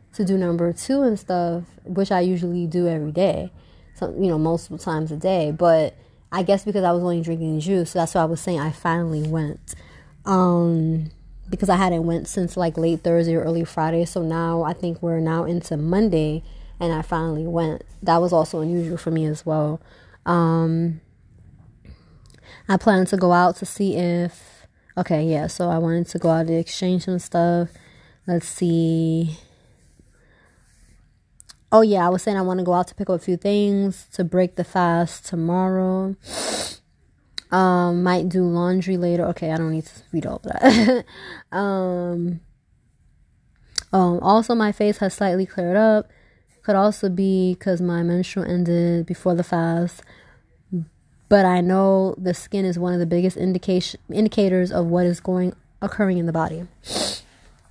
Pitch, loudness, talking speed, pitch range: 175 Hz, -21 LUFS, 175 wpm, 165-185 Hz